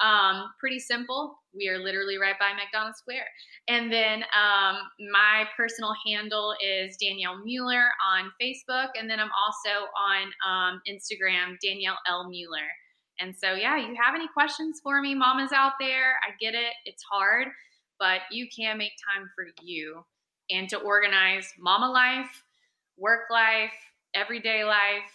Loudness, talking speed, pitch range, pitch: -25 LUFS, 155 wpm, 195-240 Hz, 210 Hz